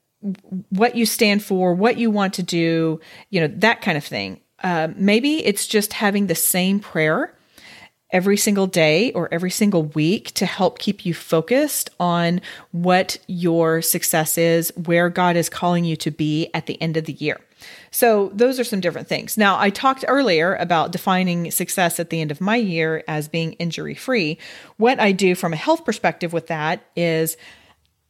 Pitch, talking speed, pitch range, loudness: 175 Hz, 185 wpm, 165-205 Hz, -19 LUFS